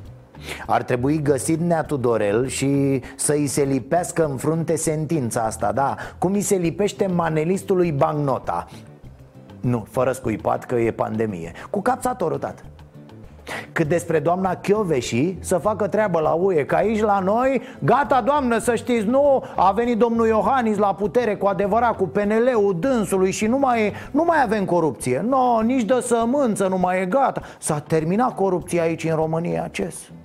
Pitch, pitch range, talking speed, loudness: 175 Hz, 140-220 Hz, 165 wpm, -21 LUFS